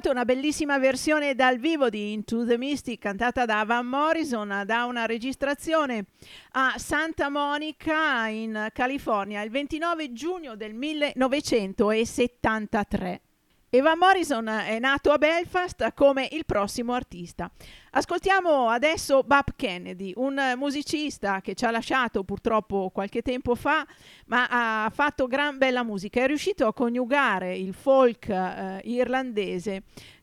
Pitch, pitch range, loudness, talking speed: 250 Hz, 220-290 Hz, -25 LUFS, 125 wpm